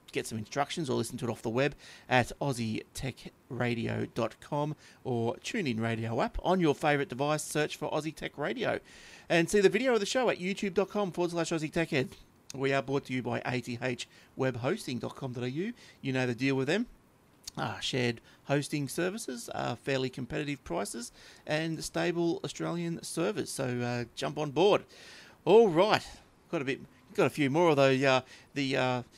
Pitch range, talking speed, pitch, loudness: 125-165 Hz, 170 wpm, 135 Hz, -31 LUFS